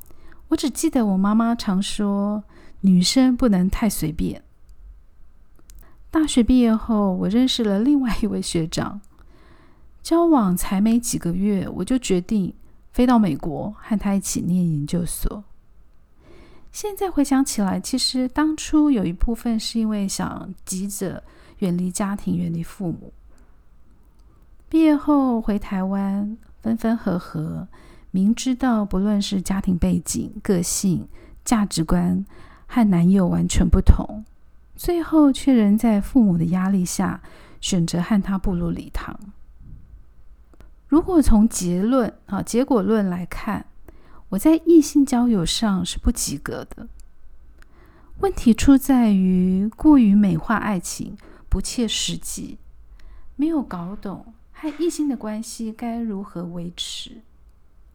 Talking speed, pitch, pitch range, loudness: 195 characters per minute, 205 Hz, 180-240 Hz, -21 LUFS